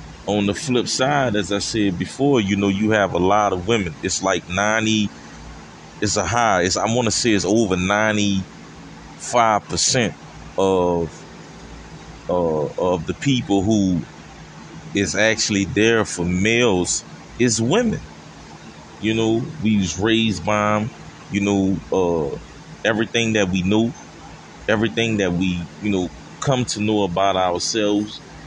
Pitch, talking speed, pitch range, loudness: 105 Hz, 140 wpm, 95-110 Hz, -20 LUFS